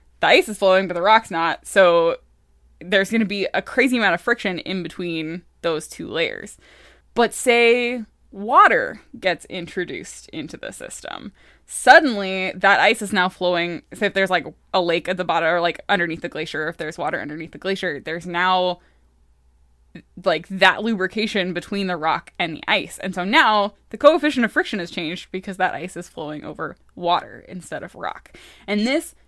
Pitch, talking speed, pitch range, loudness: 185 Hz, 185 wpm, 170-215 Hz, -20 LUFS